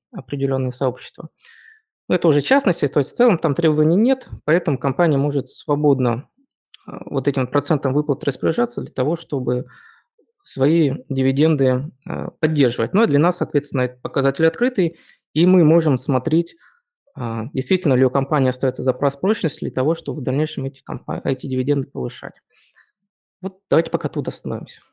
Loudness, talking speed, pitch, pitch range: -20 LUFS, 145 wpm, 145 Hz, 135-170 Hz